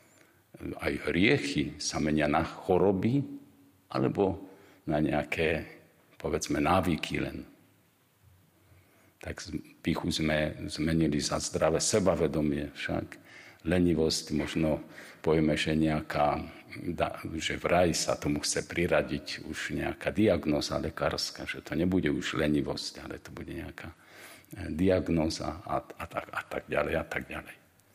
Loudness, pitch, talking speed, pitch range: -30 LUFS, 80 Hz, 115 wpm, 75-95 Hz